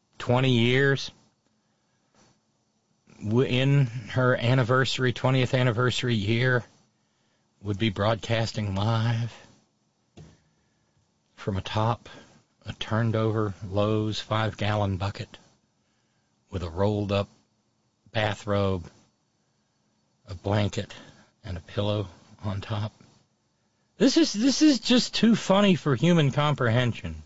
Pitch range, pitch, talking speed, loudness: 105-125 Hz, 110 Hz, 90 wpm, -25 LUFS